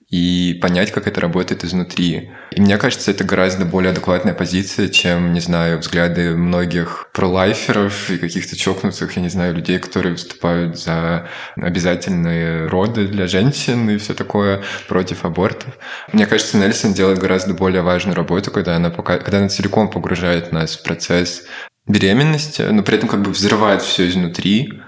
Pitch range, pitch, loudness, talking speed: 85-100 Hz, 90 Hz, -17 LUFS, 160 wpm